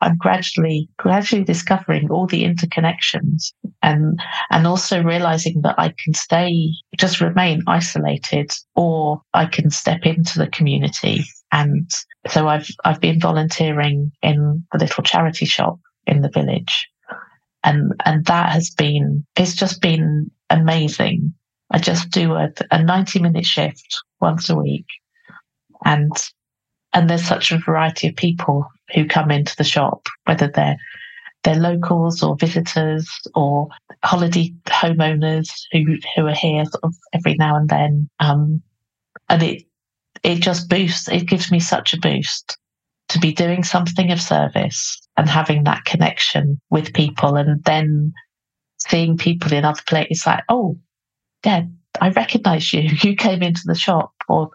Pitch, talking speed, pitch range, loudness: 165 Hz, 150 wpm, 150-175 Hz, -18 LUFS